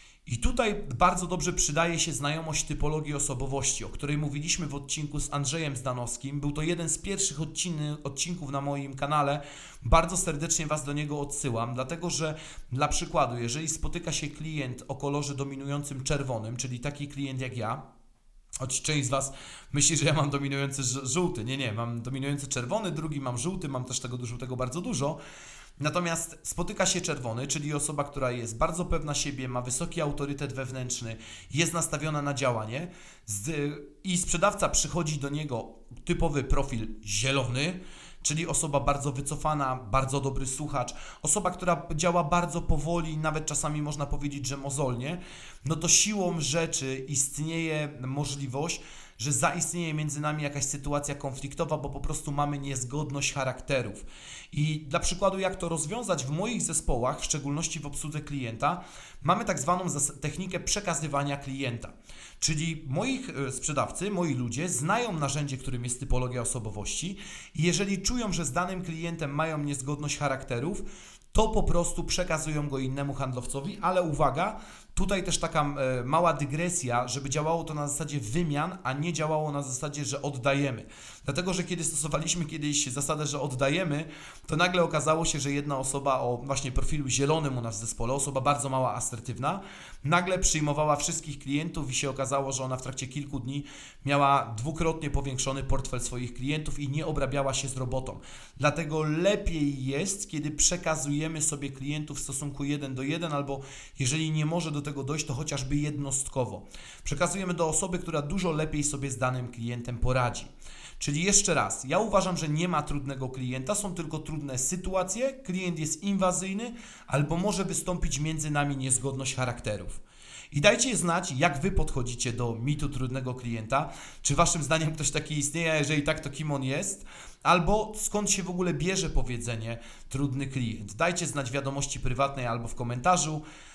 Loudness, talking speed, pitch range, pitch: -29 LUFS, 160 wpm, 135-165 Hz, 145 Hz